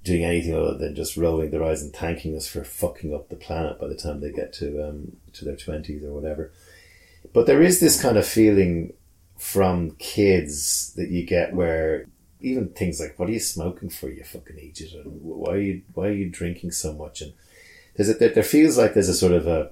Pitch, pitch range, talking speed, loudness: 85 Hz, 75-95 Hz, 220 wpm, -22 LUFS